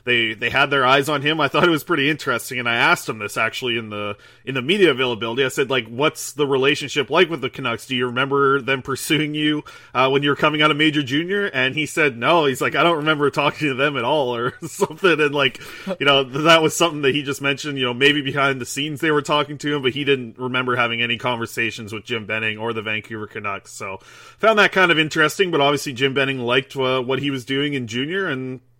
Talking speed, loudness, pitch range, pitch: 250 wpm, -19 LUFS, 125-150 Hz, 140 Hz